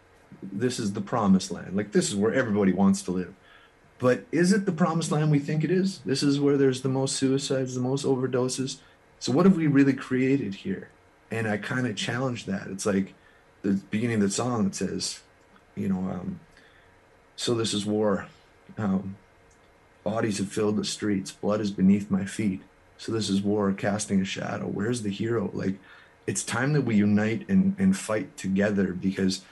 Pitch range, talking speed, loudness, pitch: 100-140 Hz, 190 wpm, -26 LUFS, 115 Hz